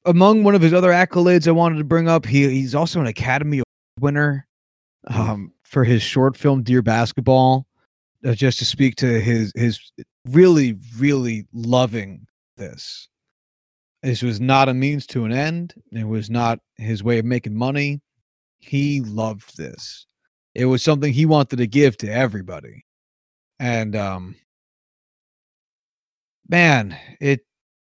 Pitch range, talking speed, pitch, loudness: 110-145 Hz, 145 wpm, 125 Hz, -18 LUFS